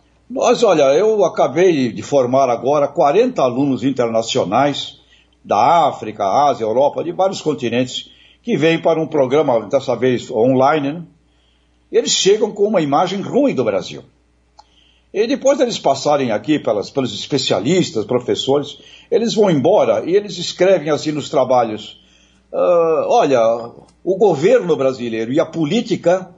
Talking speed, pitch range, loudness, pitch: 140 wpm, 120-180 Hz, -16 LUFS, 145 Hz